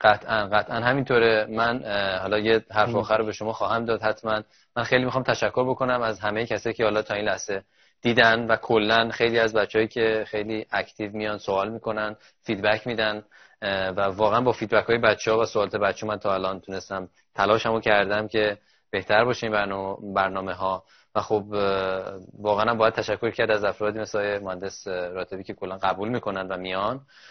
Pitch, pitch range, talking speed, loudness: 105 Hz, 100-115 Hz, 175 wpm, -24 LUFS